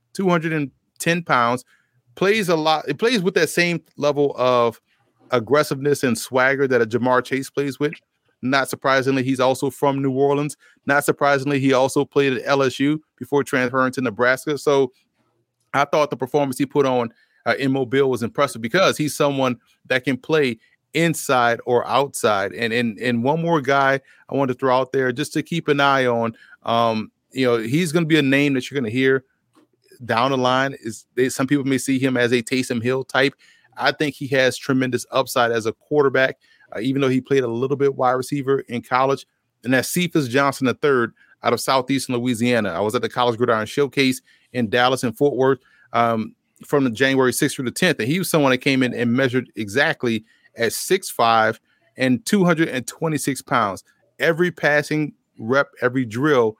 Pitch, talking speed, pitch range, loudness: 135 Hz, 190 wpm, 125-145 Hz, -20 LUFS